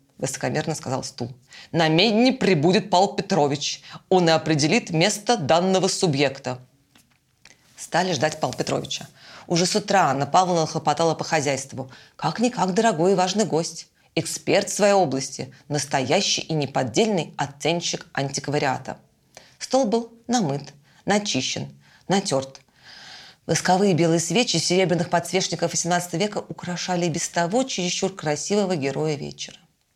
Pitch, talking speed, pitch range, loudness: 165 Hz, 115 wpm, 145-190 Hz, -22 LUFS